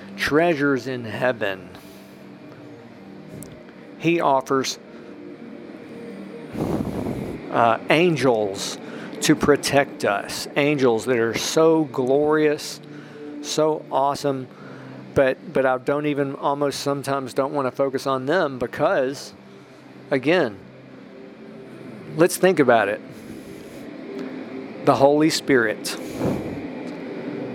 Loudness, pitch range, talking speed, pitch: -21 LUFS, 130-150 Hz, 85 wpm, 140 Hz